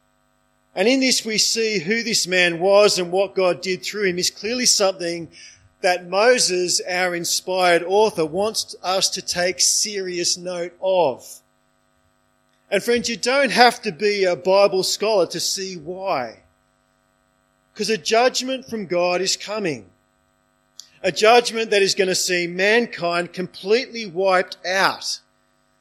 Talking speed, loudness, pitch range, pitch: 140 wpm, -19 LUFS, 175-215 Hz, 185 Hz